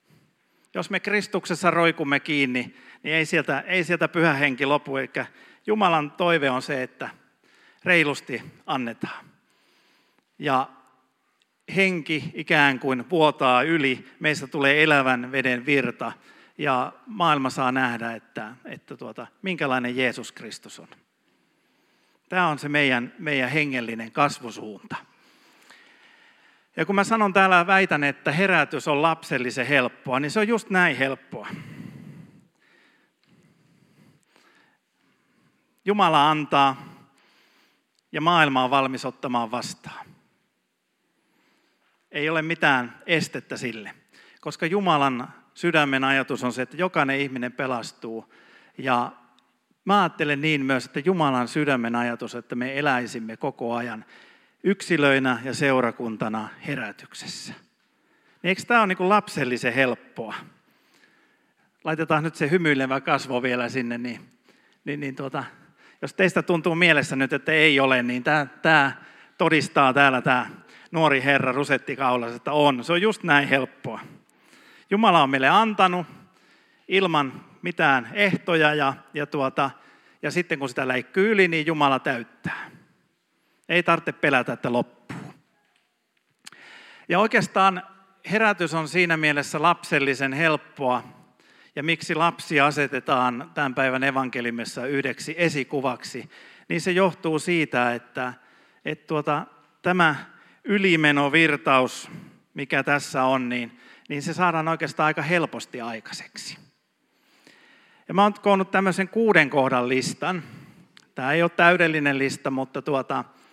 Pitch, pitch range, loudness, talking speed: 145 Hz, 135-175 Hz, -22 LUFS, 120 wpm